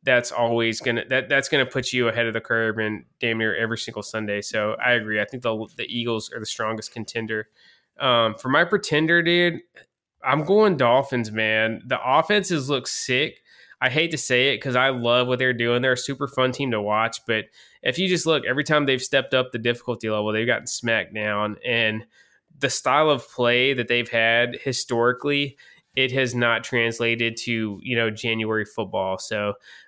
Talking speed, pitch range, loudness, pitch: 195 wpm, 110-130 Hz, -22 LUFS, 120 Hz